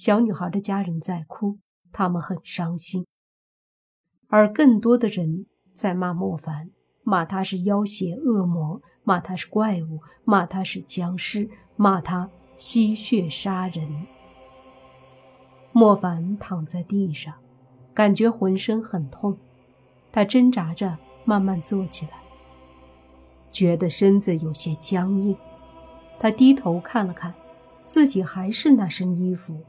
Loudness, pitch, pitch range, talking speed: -22 LUFS, 185 Hz, 160-205 Hz, 180 characters per minute